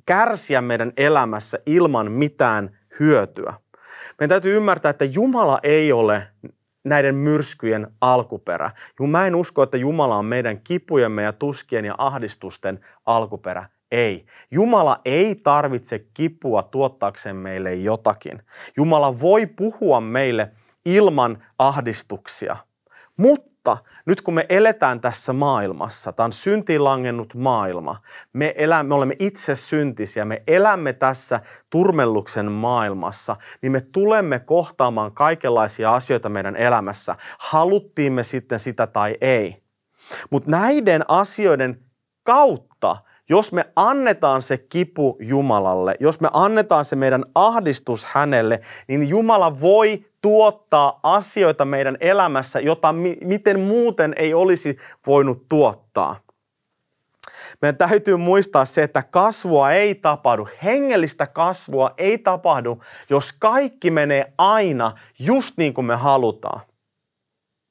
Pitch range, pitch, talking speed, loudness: 120-180 Hz, 140 Hz, 115 wpm, -19 LUFS